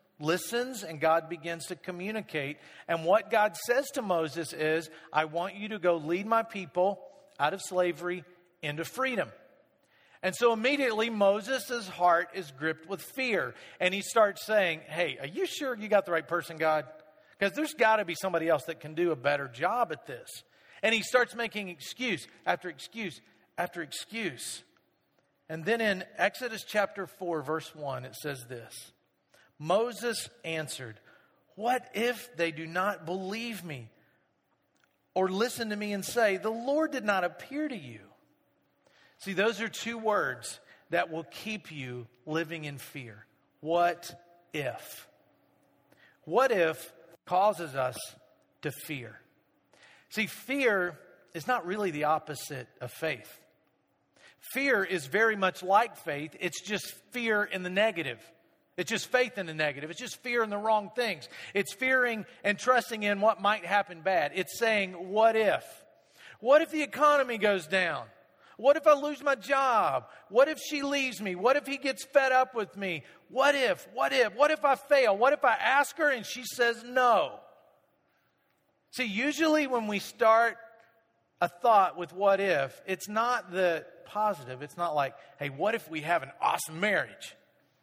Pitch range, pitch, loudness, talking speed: 165-235 Hz, 195 Hz, -29 LUFS, 165 wpm